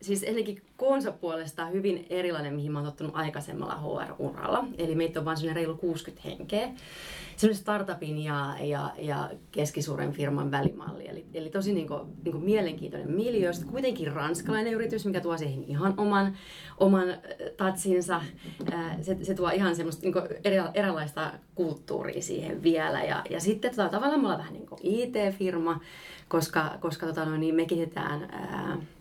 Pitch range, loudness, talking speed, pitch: 160-195 Hz, -30 LUFS, 150 wpm, 175 Hz